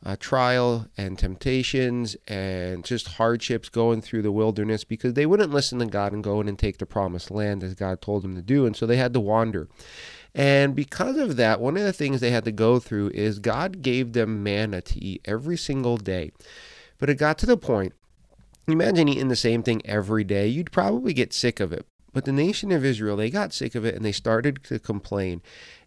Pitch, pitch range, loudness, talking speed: 115 Hz, 105-135 Hz, -24 LUFS, 220 wpm